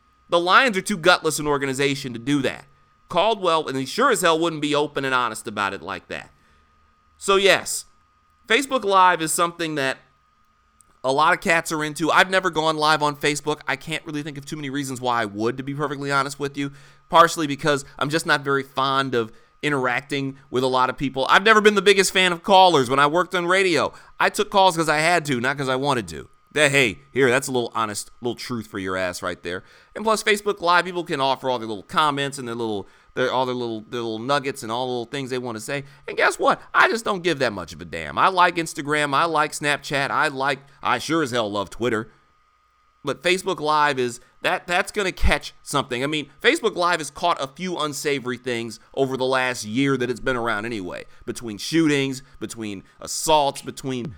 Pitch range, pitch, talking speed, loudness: 125-165 Hz, 140 Hz, 225 wpm, -21 LUFS